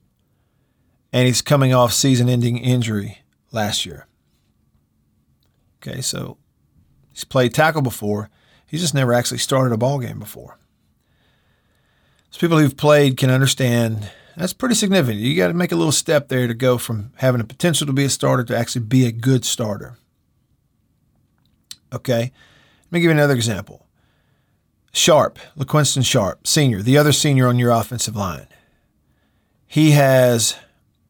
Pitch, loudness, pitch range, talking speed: 125 Hz, -17 LUFS, 120-145 Hz, 145 wpm